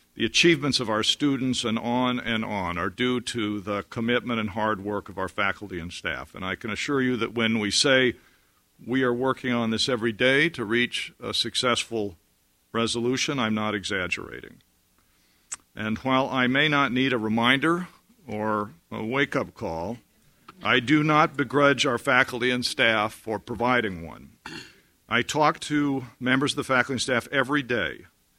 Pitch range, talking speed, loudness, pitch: 110-130 Hz, 170 wpm, -24 LUFS, 120 Hz